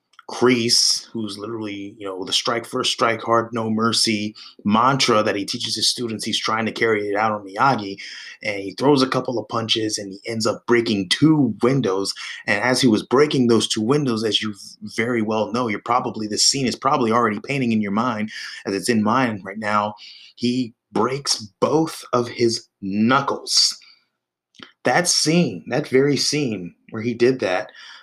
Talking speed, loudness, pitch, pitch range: 180 wpm, -20 LUFS, 115 Hz, 105-125 Hz